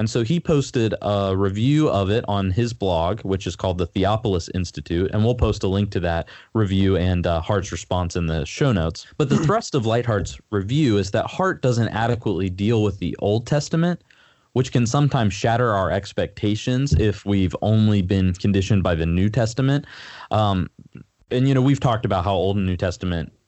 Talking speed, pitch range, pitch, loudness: 195 wpm, 95-120 Hz, 100 Hz, -21 LUFS